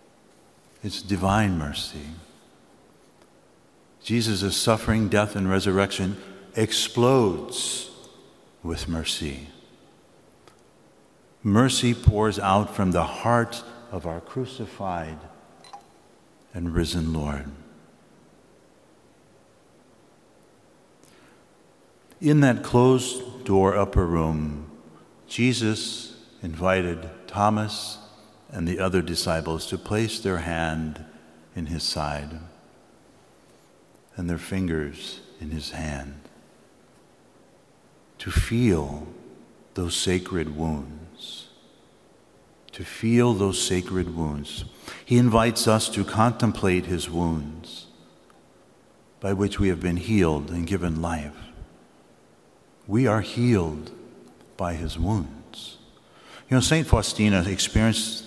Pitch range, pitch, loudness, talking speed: 80-110 Hz, 95 Hz, -24 LUFS, 90 wpm